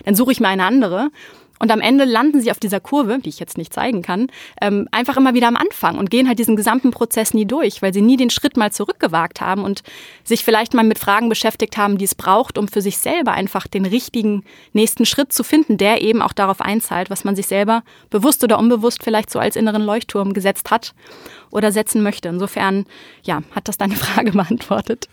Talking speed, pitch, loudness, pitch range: 220 wpm, 220 Hz, -17 LUFS, 200-240 Hz